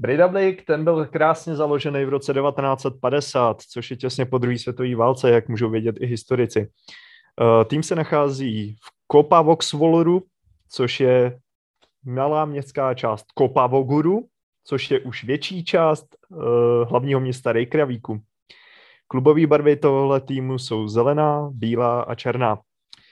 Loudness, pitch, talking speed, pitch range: -20 LUFS, 135 Hz, 125 wpm, 120-150 Hz